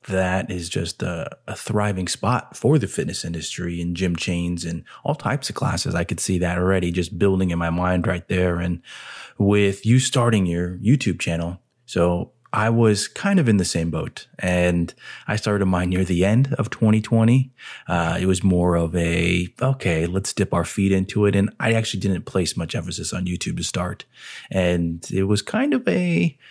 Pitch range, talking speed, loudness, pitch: 85-105 Hz, 195 wpm, -22 LUFS, 90 Hz